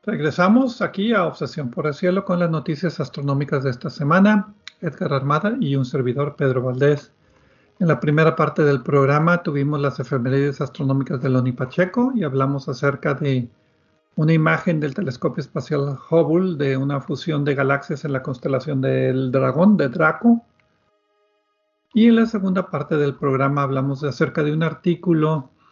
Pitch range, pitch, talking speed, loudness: 140-175 Hz, 150 Hz, 160 wpm, -20 LUFS